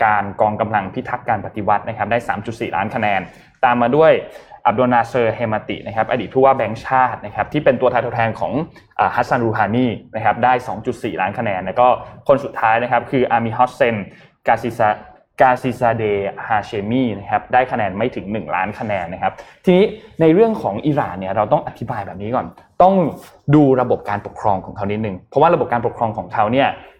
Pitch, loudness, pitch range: 120 Hz, -18 LUFS, 105-130 Hz